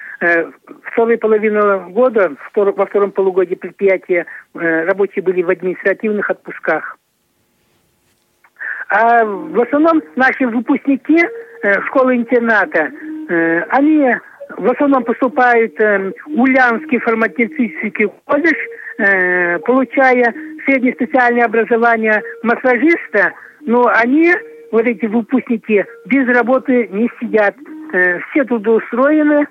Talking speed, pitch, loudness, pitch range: 90 wpm, 235 Hz, -14 LUFS, 205-270 Hz